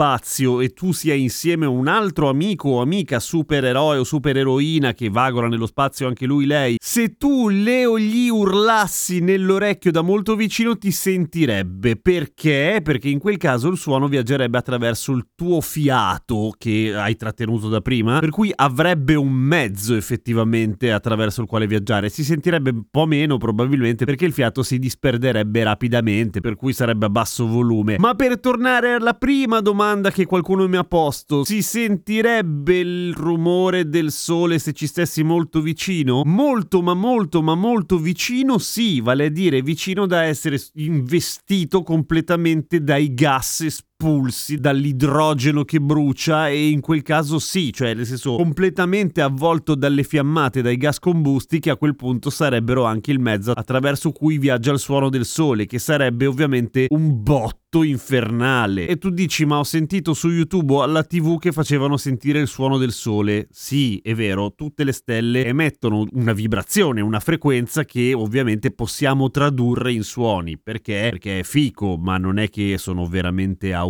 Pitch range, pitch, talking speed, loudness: 120-170 Hz, 145 Hz, 165 wpm, -19 LUFS